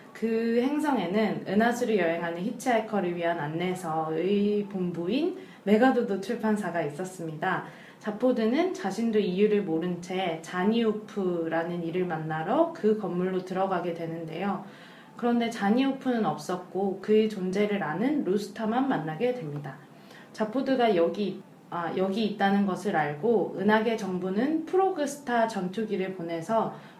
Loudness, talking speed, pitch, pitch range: -28 LUFS, 310 characters per minute, 205 Hz, 180-230 Hz